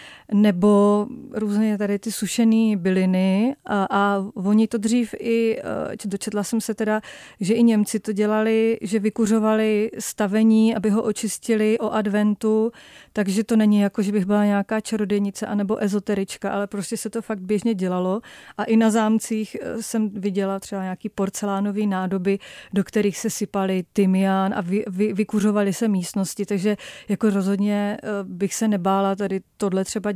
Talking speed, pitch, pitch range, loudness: 155 wpm, 210 Hz, 200-220 Hz, -22 LUFS